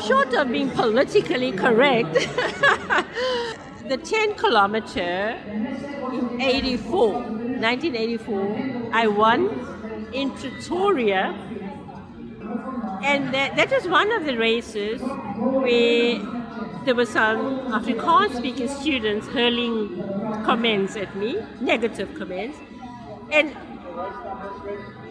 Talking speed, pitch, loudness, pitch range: 85 wpm, 240 Hz, -22 LUFS, 215-270 Hz